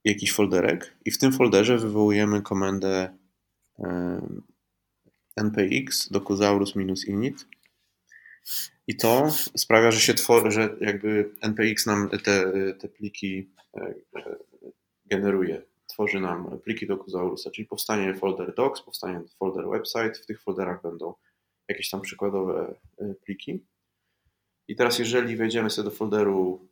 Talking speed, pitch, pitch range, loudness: 110 wpm, 100 Hz, 95-110 Hz, -25 LUFS